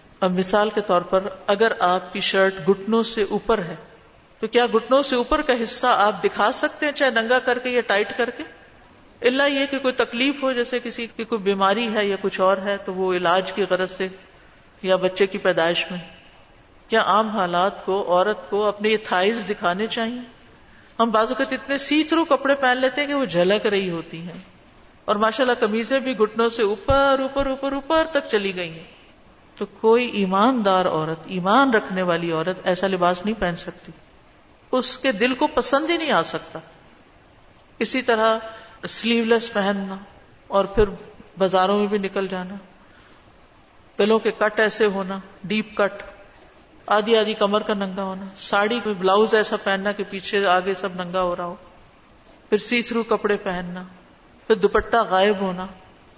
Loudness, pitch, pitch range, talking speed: -21 LUFS, 210 Hz, 190-235 Hz, 180 wpm